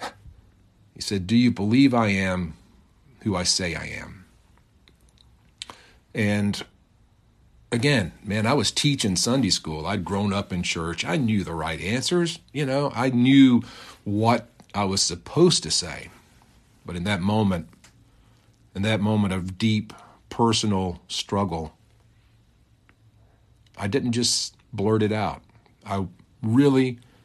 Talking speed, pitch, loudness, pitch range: 130 wpm, 105 Hz, -23 LUFS, 95-115 Hz